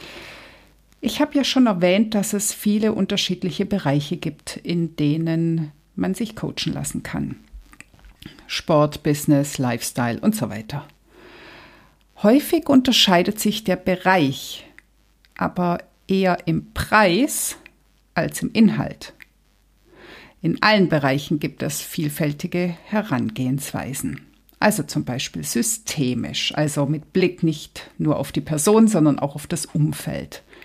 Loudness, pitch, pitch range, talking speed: -21 LUFS, 175 Hz, 150-210 Hz, 115 wpm